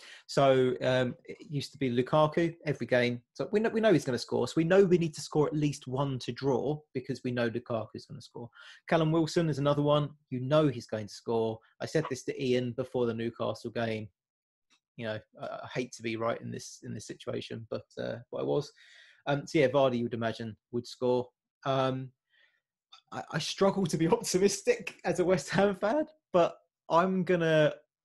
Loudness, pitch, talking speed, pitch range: -30 LUFS, 135 Hz, 210 wpm, 120-165 Hz